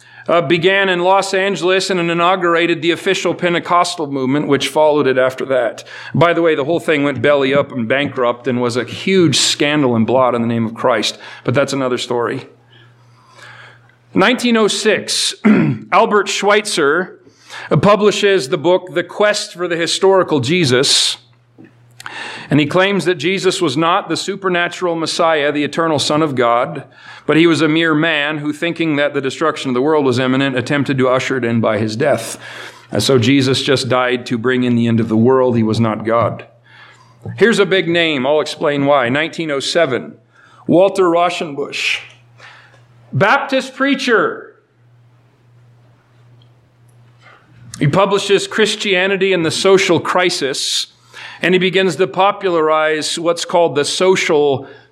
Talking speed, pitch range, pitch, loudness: 150 wpm, 130-180 Hz, 155 Hz, -14 LUFS